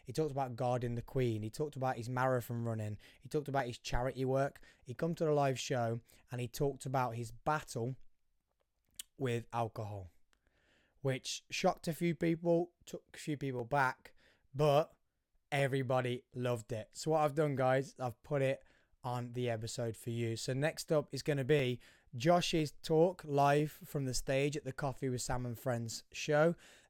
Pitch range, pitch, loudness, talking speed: 120-150 Hz, 130 Hz, -36 LUFS, 180 wpm